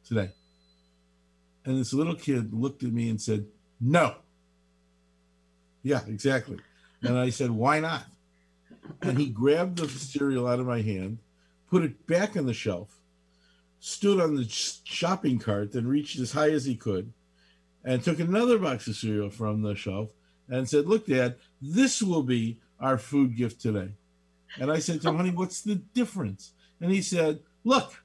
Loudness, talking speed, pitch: -28 LUFS, 165 wpm, 120 Hz